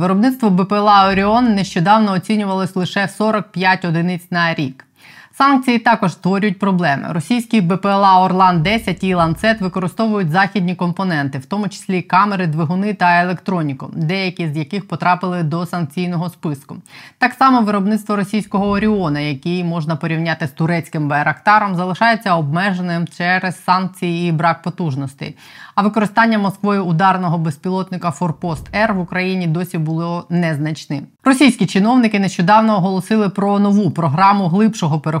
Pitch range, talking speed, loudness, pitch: 170-205 Hz, 130 wpm, -16 LUFS, 185 Hz